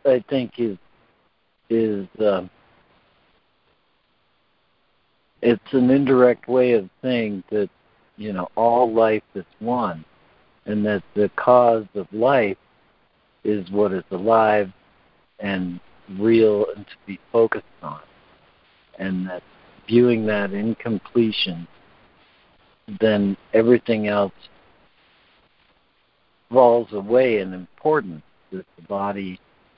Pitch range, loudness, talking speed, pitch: 95-115 Hz, -21 LUFS, 105 wpm, 105 Hz